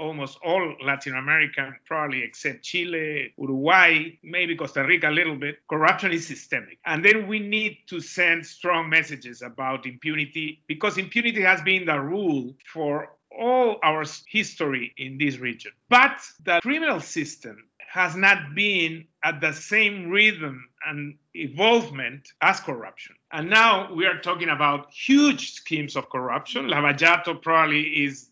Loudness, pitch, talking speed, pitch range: -22 LUFS, 155 Hz, 145 wpm, 145-185 Hz